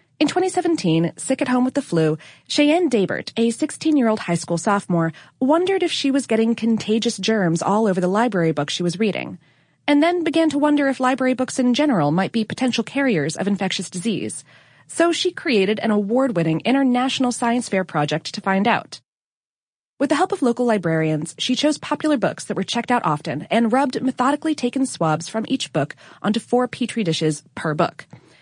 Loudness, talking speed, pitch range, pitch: -20 LUFS, 185 wpm, 180-270 Hz, 230 Hz